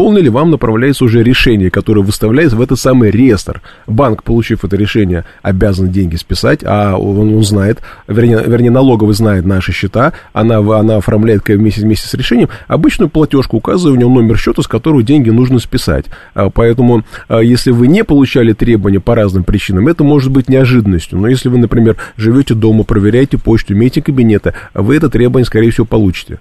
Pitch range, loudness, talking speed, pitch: 105-130 Hz, -10 LUFS, 175 wpm, 115 Hz